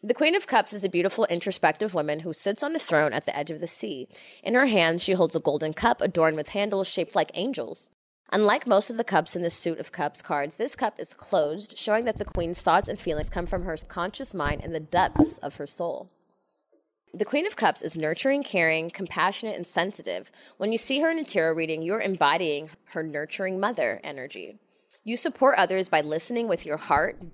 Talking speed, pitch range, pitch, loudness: 215 wpm, 160-220 Hz, 185 Hz, -26 LUFS